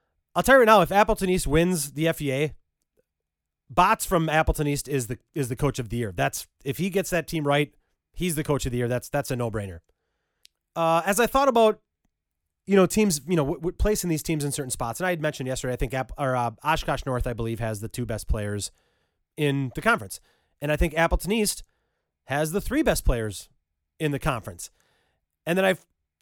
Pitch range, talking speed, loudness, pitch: 120-175 Hz, 225 wpm, -25 LUFS, 145 Hz